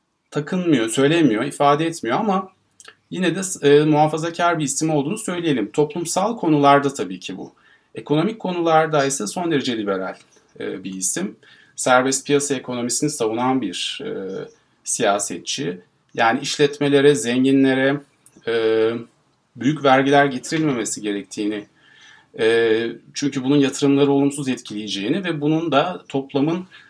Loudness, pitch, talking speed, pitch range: -19 LUFS, 140 Hz, 115 wpm, 125-155 Hz